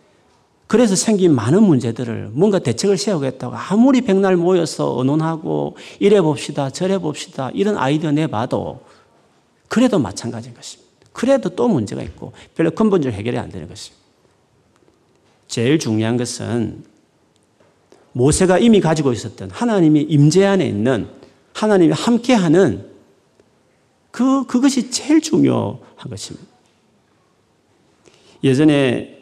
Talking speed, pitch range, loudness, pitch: 290 characters per minute, 125-200 Hz, -17 LUFS, 155 Hz